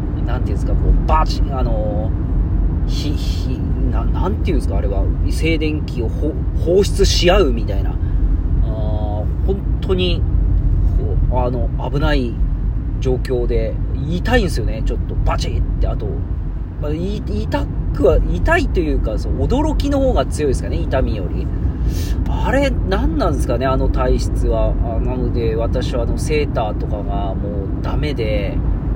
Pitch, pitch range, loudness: 85 Hz, 80-95 Hz, -19 LUFS